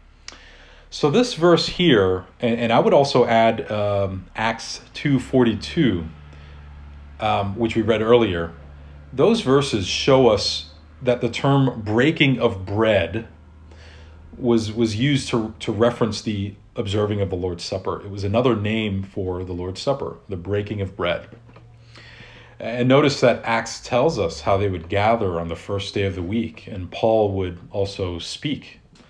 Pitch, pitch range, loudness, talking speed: 105 Hz, 90-120 Hz, -21 LUFS, 155 wpm